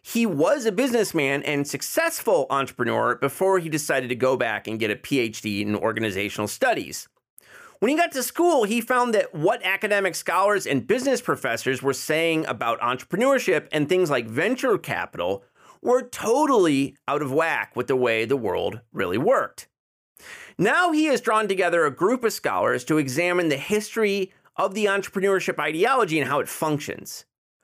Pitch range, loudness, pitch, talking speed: 140-230 Hz, -23 LUFS, 185 Hz, 165 wpm